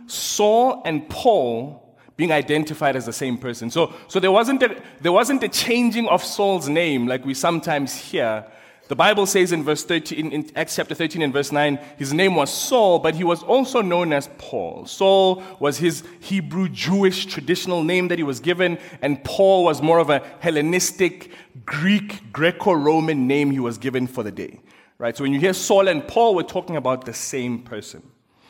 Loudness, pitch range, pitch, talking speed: -20 LUFS, 140-185 Hz, 165 Hz, 190 wpm